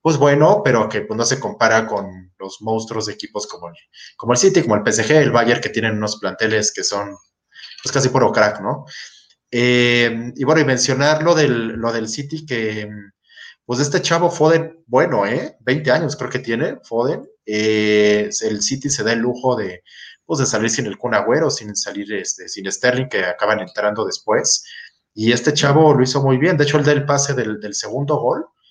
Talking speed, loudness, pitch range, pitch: 200 wpm, -17 LUFS, 105-145 Hz, 120 Hz